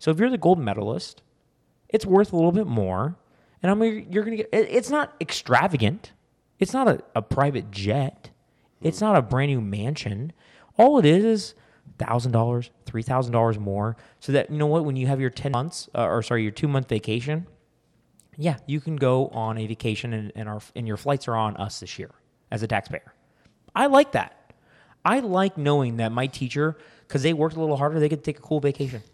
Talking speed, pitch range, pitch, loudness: 210 wpm, 115-165 Hz, 140 Hz, -24 LUFS